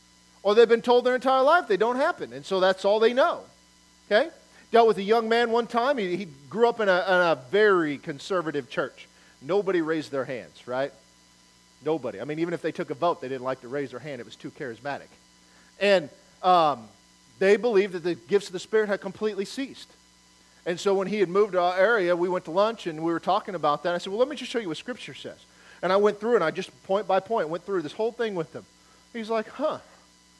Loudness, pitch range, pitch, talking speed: -25 LUFS, 160-225 Hz, 190 Hz, 245 wpm